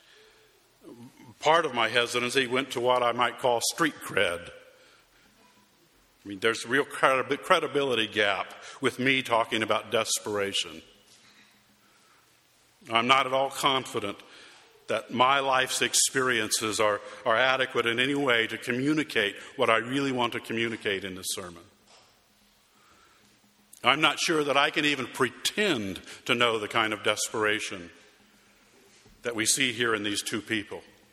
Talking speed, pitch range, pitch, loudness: 140 wpm, 110-135 Hz, 125 Hz, -26 LUFS